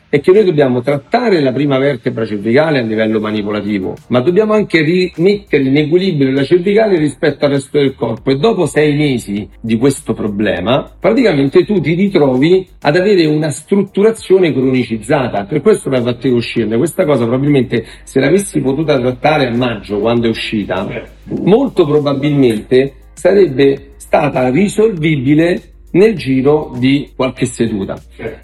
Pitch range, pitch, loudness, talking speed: 125-170 Hz, 140 Hz, -13 LUFS, 145 wpm